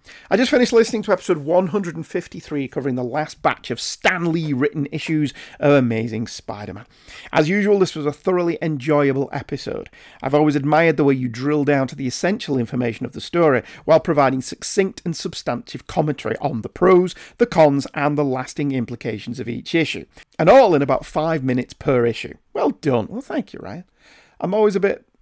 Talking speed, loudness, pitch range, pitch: 190 wpm, -20 LUFS, 130-170 Hz, 150 Hz